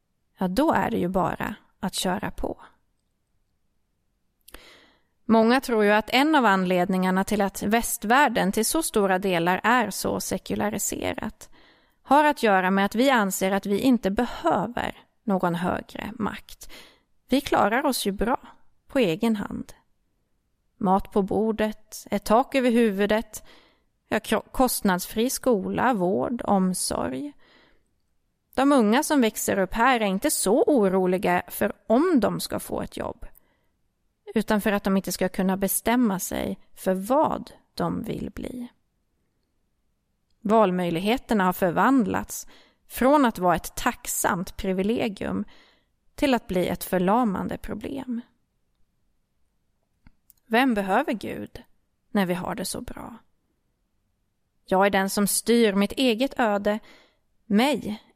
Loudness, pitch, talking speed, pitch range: -24 LUFS, 210 Hz, 125 wpm, 190-245 Hz